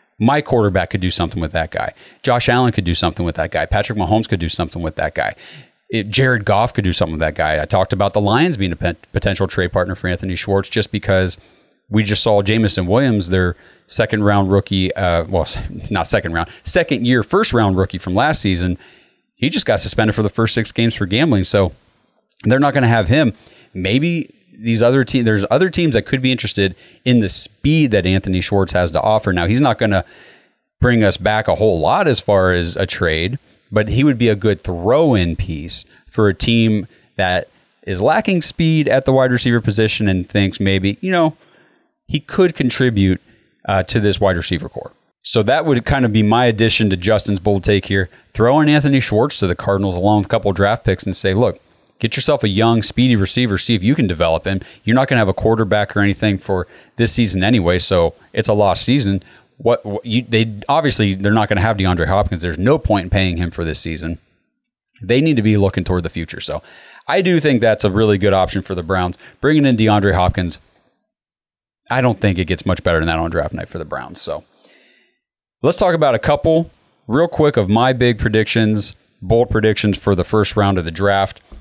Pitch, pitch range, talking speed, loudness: 105 Hz, 95-120 Hz, 220 wpm, -16 LUFS